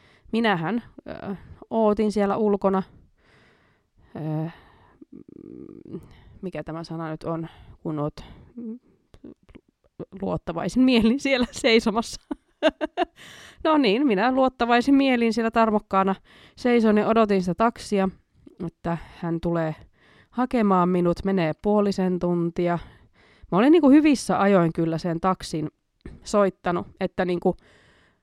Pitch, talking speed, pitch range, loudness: 195 Hz, 105 wpm, 170-235 Hz, -23 LUFS